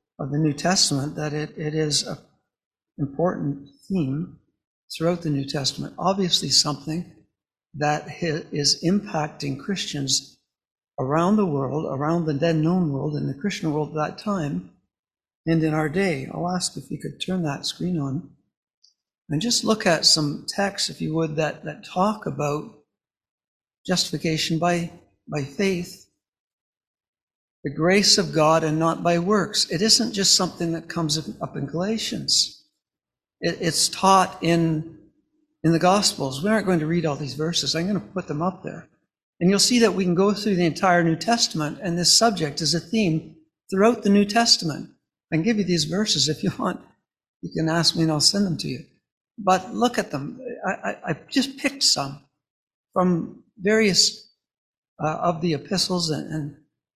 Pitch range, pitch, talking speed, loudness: 150-195 Hz, 165 Hz, 170 wpm, -22 LUFS